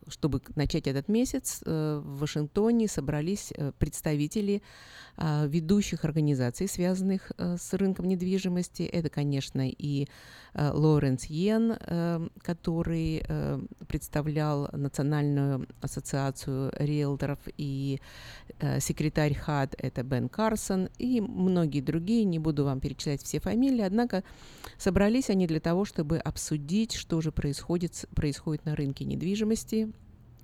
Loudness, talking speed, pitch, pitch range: -30 LUFS, 105 wpm, 155 Hz, 145-190 Hz